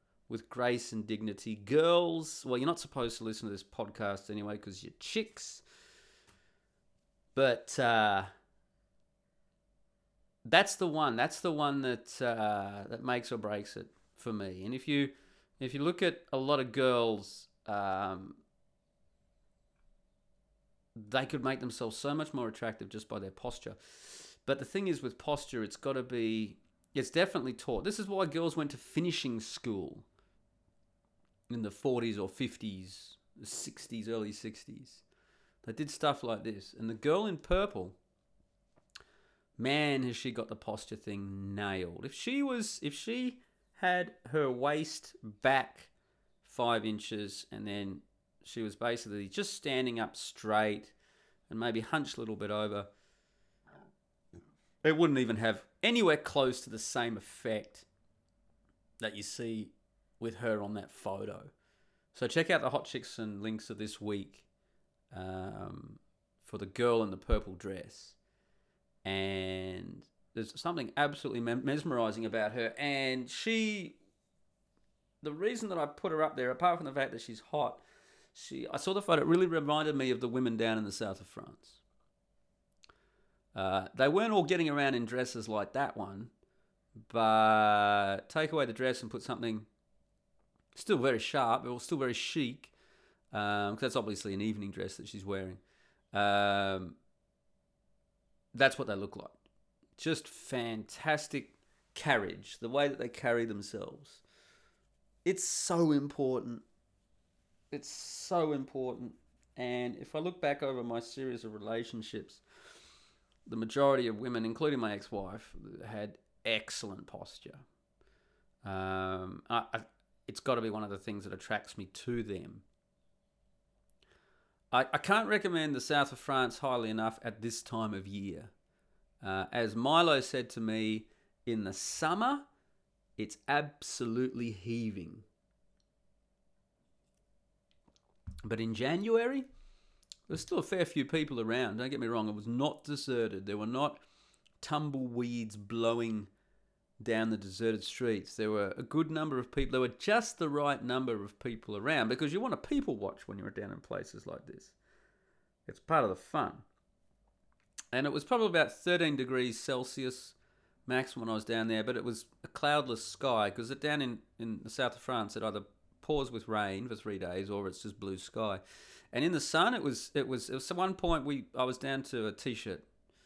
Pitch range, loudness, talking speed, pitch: 105-140 Hz, -35 LUFS, 160 wpm, 115 Hz